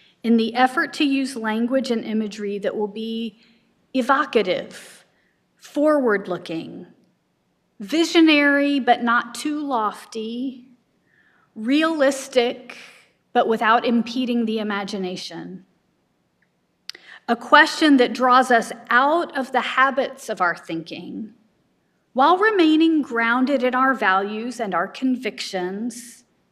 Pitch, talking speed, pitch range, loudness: 235 Hz, 105 wpm, 215-270 Hz, -20 LUFS